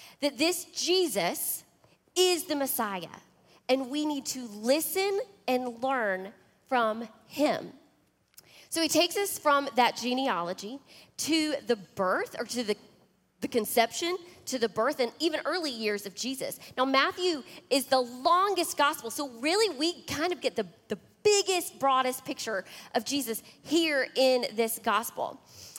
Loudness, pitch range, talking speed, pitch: -29 LUFS, 235-325 Hz, 145 wpm, 270 Hz